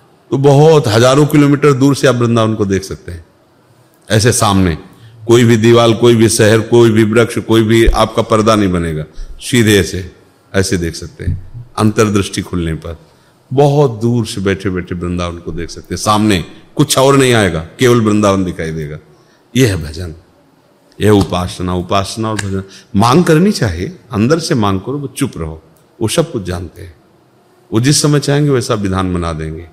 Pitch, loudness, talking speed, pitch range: 105 Hz, -12 LUFS, 180 wpm, 90-120 Hz